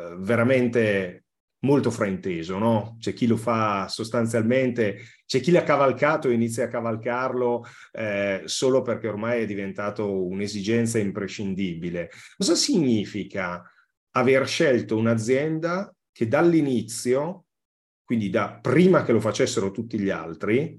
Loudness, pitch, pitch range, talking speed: -24 LUFS, 115 Hz, 100-130 Hz, 120 wpm